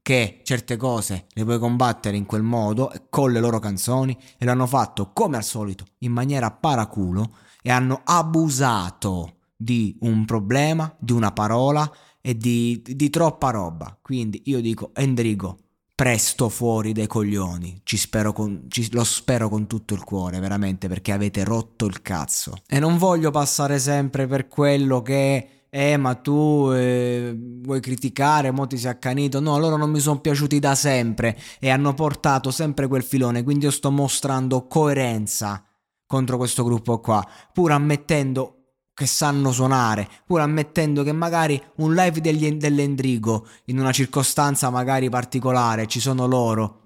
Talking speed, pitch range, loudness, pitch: 155 wpm, 110-140 Hz, -22 LUFS, 125 Hz